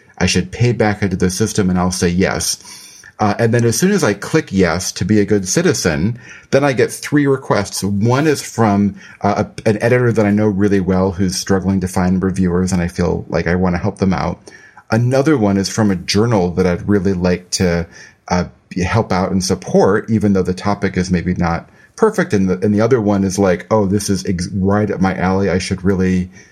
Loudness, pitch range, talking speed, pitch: -16 LUFS, 90-105 Hz, 225 wpm, 100 Hz